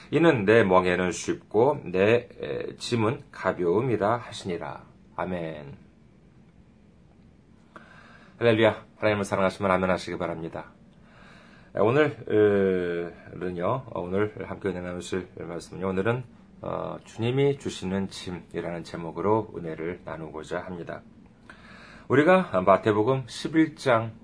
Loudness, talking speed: -26 LUFS, 235 characters per minute